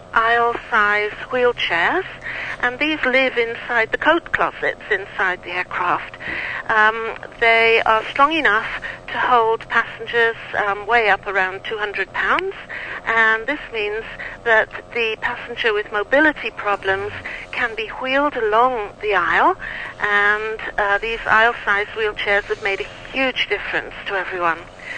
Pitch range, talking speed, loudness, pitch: 210-260 Hz, 130 wpm, -19 LUFS, 230 Hz